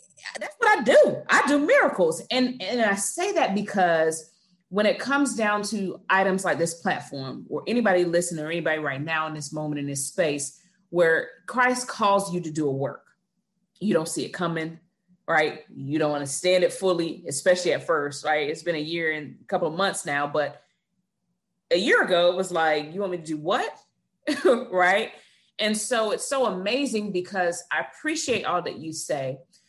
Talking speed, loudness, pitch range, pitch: 190 wpm, -24 LUFS, 155-205 Hz, 180 Hz